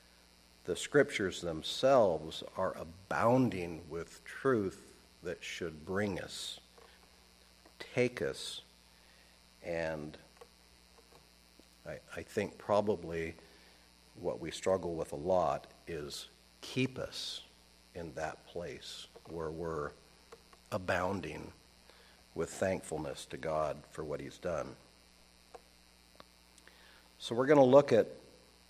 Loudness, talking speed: -35 LUFS, 100 wpm